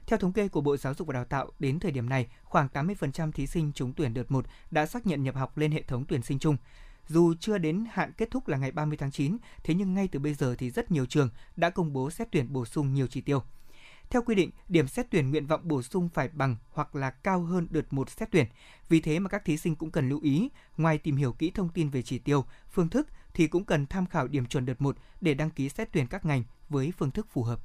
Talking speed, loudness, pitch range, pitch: 275 wpm, -30 LUFS, 135-175 Hz, 150 Hz